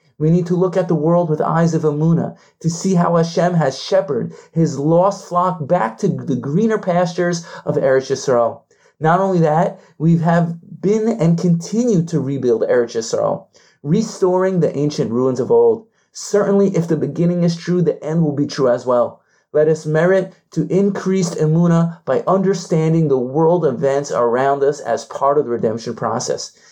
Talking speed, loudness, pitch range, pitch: 175 wpm, -17 LUFS, 150-185 Hz, 170 Hz